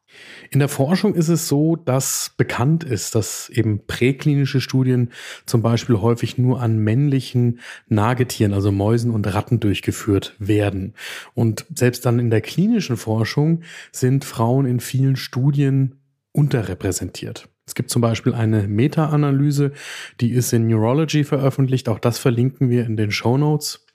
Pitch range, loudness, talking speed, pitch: 115-140 Hz, -19 LUFS, 145 wpm, 125 Hz